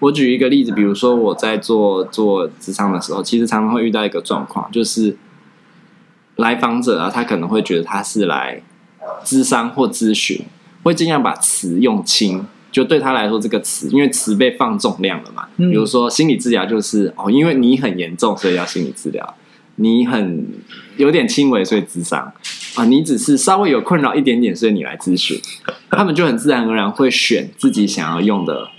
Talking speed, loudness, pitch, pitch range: 295 characters per minute, -16 LUFS, 120 Hz, 110-145 Hz